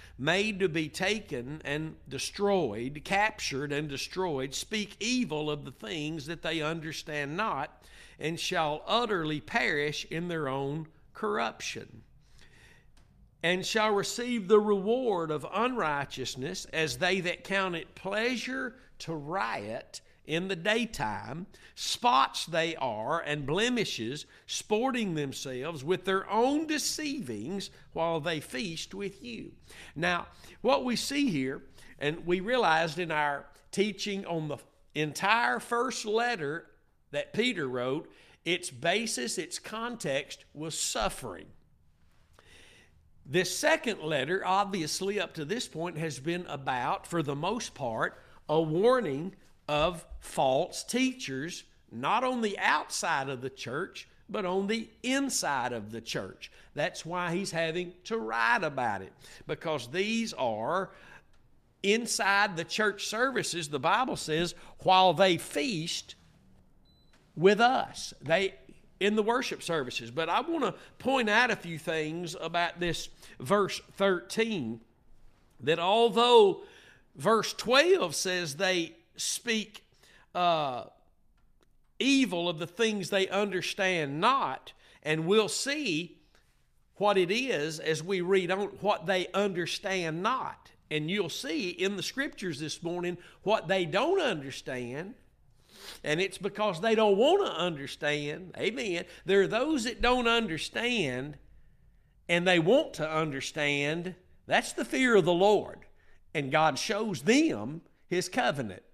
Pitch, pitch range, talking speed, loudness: 180 Hz, 155-210 Hz, 130 wpm, -30 LUFS